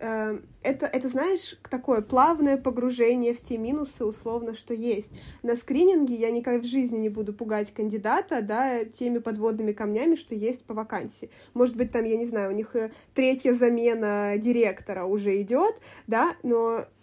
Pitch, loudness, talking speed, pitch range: 235 Hz, -26 LUFS, 160 wpm, 220-260 Hz